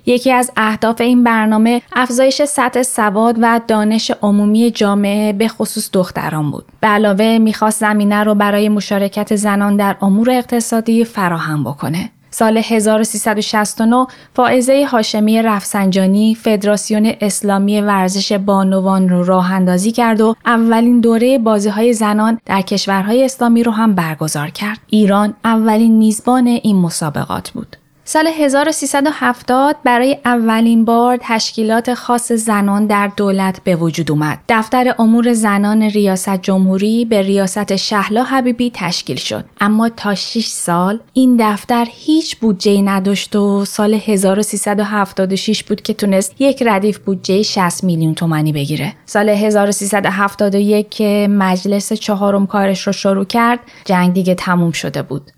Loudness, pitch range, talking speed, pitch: -13 LUFS, 200-230 Hz, 130 wpm, 210 Hz